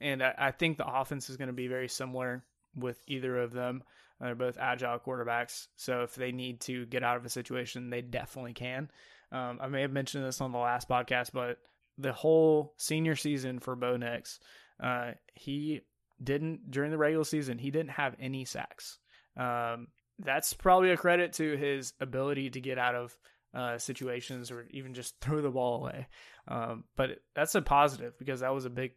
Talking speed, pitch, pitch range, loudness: 195 wpm, 130 Hz, 125-140 Hz, -33 LUFS